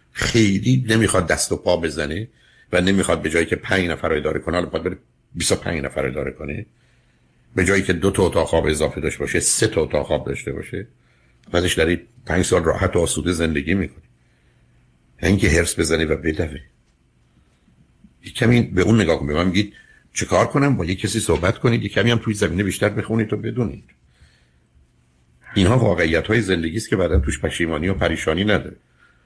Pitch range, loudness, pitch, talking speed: 80-110 Hz, -20 LUFS, 95 Hz, 185 wpm